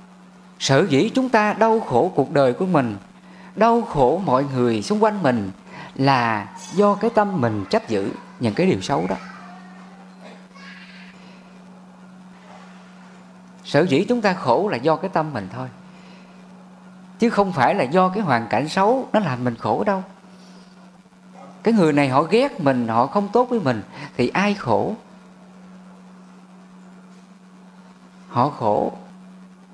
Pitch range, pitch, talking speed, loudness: 155-195 Hz, 185 Hz, 140 wpm, -20 LUFS